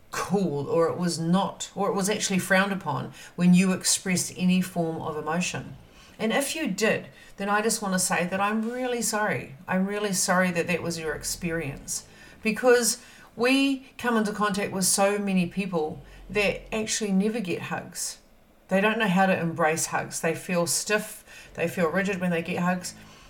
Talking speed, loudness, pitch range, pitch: 185 wpm, -26 LUFS, 170-210 Hz, 190 Hz